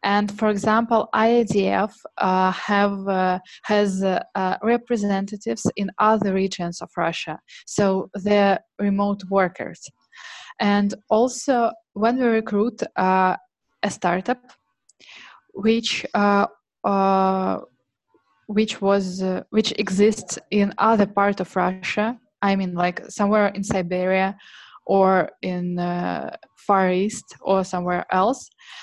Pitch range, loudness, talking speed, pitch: 185-215 Hz, -22 LUFS, 115 wpm, 200 Hz